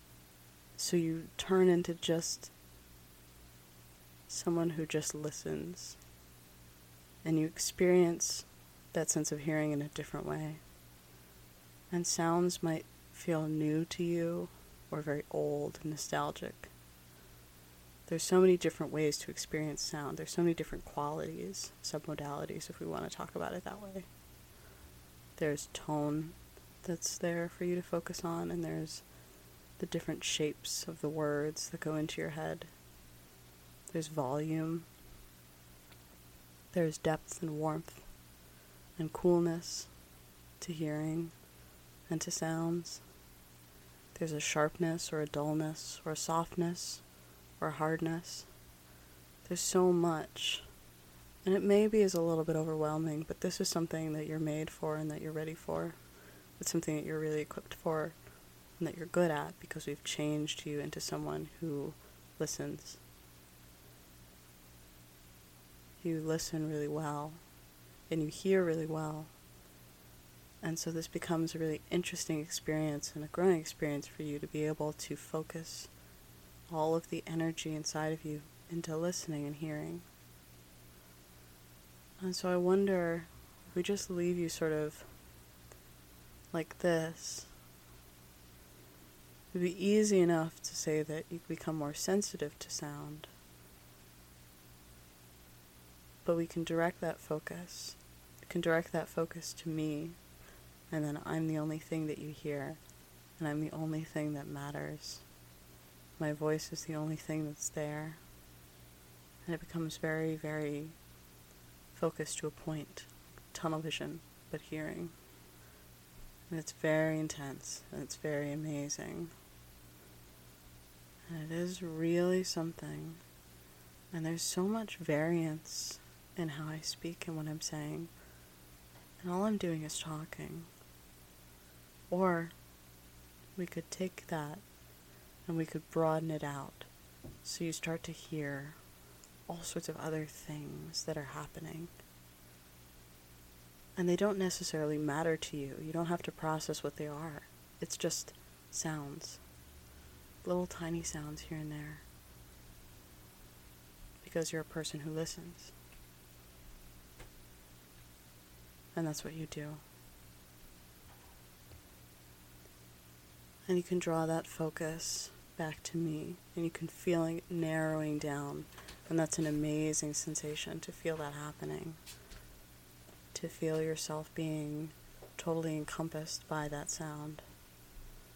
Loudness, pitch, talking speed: -37 LUFS, 150 Hz, 130 wpm